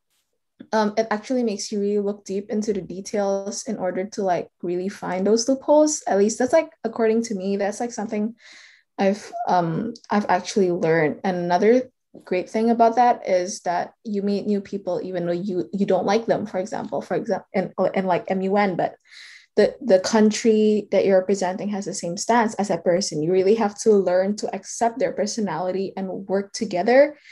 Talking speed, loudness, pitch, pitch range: 190 wpm, -22 LUFS, 200 Hz, 185-225 Hz